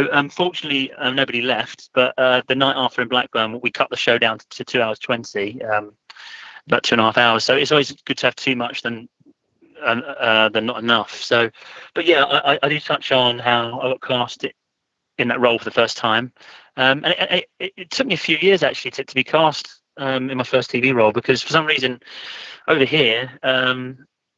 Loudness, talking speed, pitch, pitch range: -18 LUFS, 215 wpm, 130 Hz, 120-140 Hz